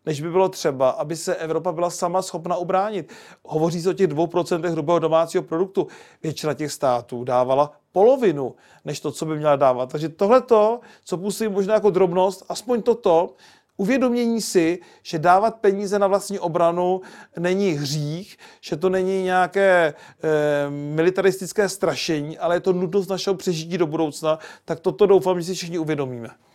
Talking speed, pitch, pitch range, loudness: 165 wpm, 180 Hz, 160-195 Hz, -21 LUFS